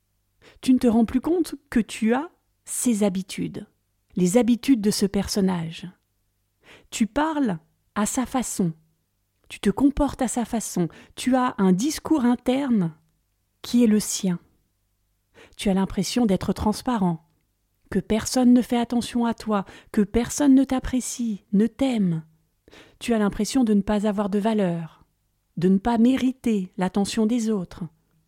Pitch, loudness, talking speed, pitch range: 210 Hz, -23 LUFS, 150 wpm, 170-245 Hz